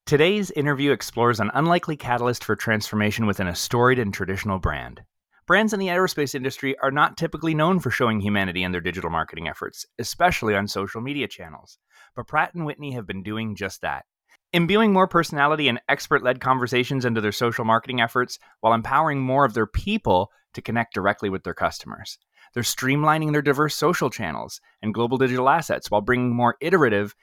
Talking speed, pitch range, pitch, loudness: 180 wpm, 105-145 Hz, 125 Hz, -22 LUFS